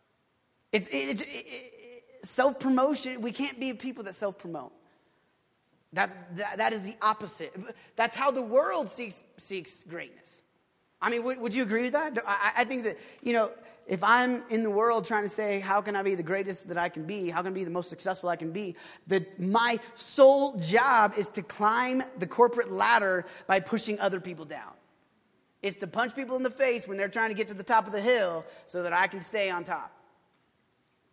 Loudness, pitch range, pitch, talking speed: -28 LUFS, 190-245 Hz, 215 Hz, 200 wpm